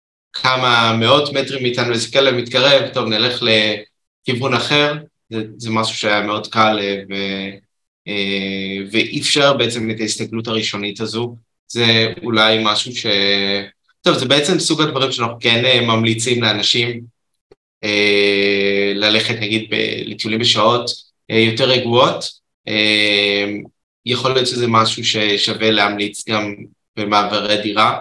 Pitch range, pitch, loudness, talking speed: 105-120 Hz, 110 Hz, -15 LUFS, 115 wpm